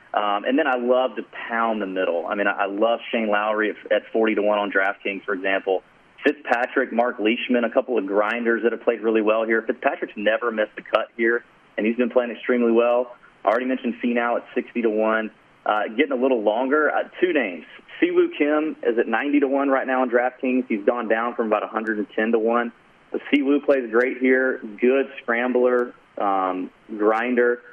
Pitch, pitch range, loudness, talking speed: 120 Hz, 110-125 Hz, -22 LUFS, 200 wpm